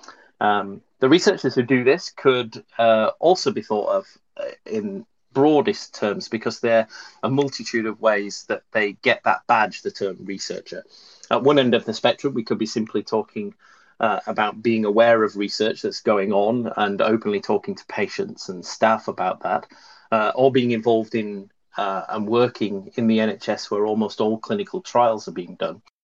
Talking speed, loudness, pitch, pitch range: 180 wpm, -21 LUFS, 115 Hz, 105-135 Hz